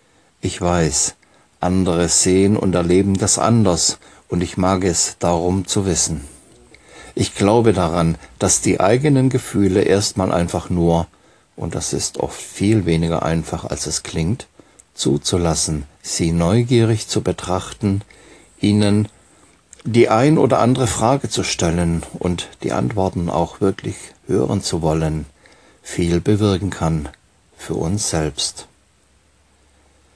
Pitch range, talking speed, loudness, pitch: 80-100 Hz, 125 wpm, -18 LUFS, 90 Hz